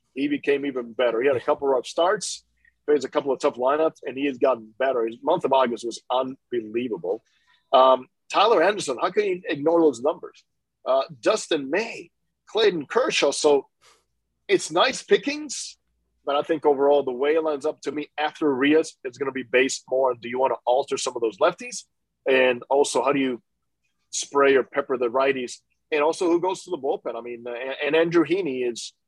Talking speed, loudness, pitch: 200 wpm, -23 LUFS, 145 Hz